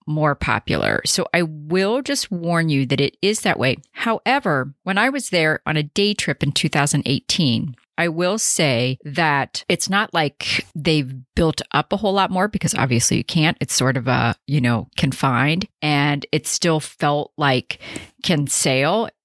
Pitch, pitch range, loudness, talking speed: 155 Hz, 140-185 Hz, -19 LUFS, 175 wpm